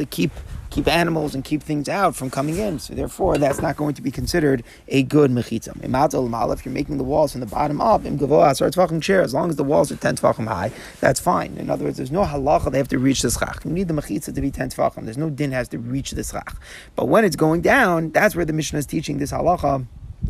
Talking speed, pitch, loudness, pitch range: 250 wpm, 145 Hz, -21 LUFS, 130-155 Hz